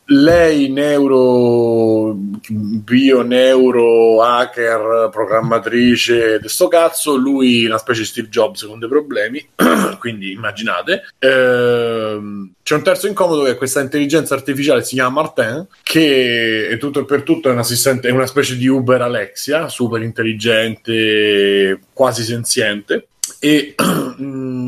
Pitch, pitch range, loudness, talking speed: 120 Hz, 115-140 Hz, -14 LUFS, 130 wpm